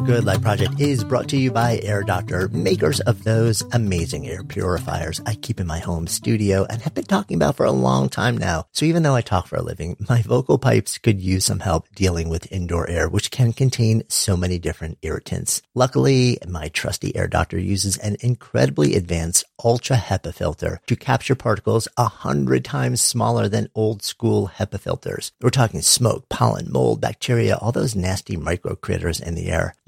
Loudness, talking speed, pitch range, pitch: -21 LUFS, 190 wpm, 90-120 Hz, 105 Hz